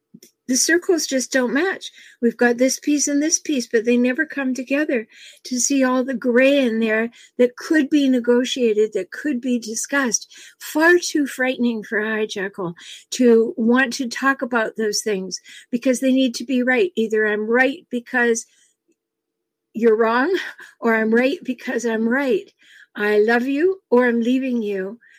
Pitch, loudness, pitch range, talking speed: 250 Hz, -19 LUFS, 230-275 Hz, 165 wpm